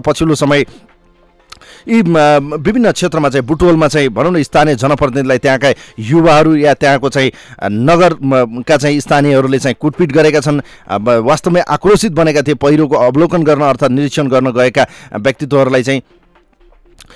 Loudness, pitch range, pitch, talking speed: -11 LUFS, 135-155 Hz, 145 Hz, 130 wpm